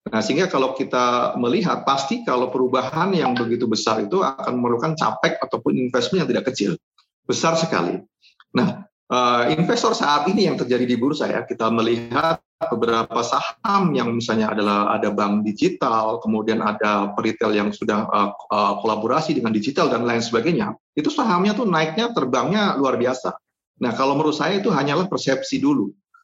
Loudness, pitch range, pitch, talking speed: -21 LUFS, 115-180 Hz, 125 Hz, 160 wpm